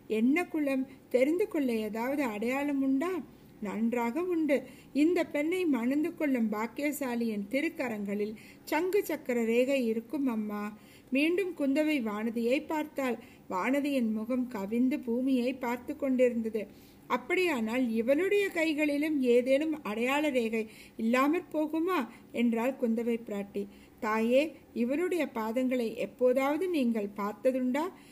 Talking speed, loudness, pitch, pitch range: 100 wpm, -30 LUFS, 260 Hz, 230-300 Hz